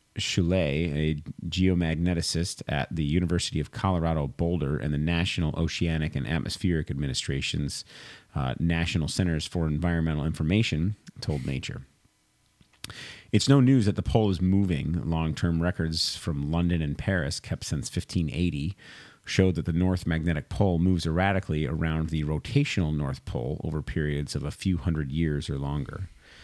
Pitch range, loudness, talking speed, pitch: 75-95 Hz, -27 LUFS, 145 wpm, 85 Hz